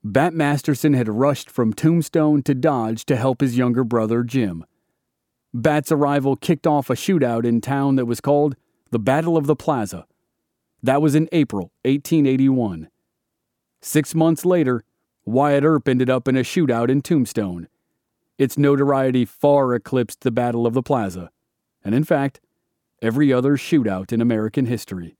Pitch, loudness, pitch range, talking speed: 135 Hz, -19 LUFS, 120-145 Hz, 155 wpm